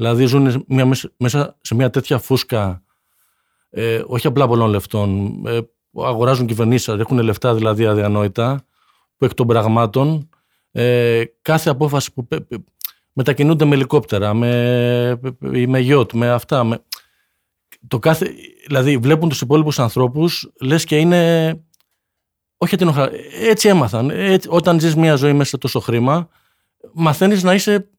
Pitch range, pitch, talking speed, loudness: 115-155 Hz, 130 Hz, 135 wpm, -16 LUFS